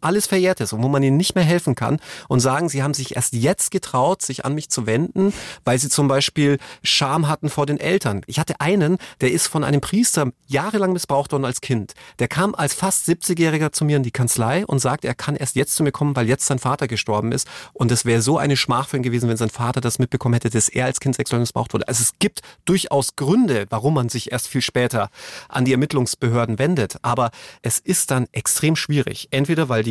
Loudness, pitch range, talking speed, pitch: -20 LUFS, 125-160 Hz, 230 wpm, 140 Hz